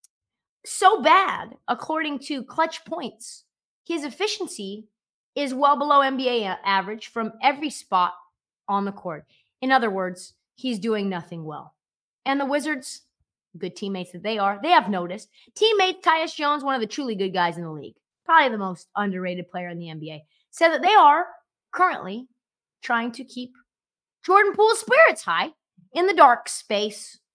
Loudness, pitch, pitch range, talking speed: -22 LUFS, 240 Hz, 195-300 Hz, 160 wpm